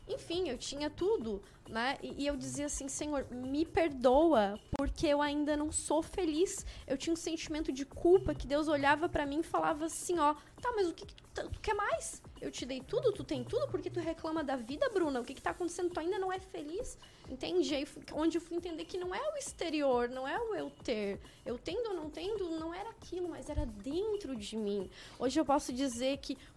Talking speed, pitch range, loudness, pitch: 225 wpm, 275-355 Hz, -35 LUFS, 315 Hz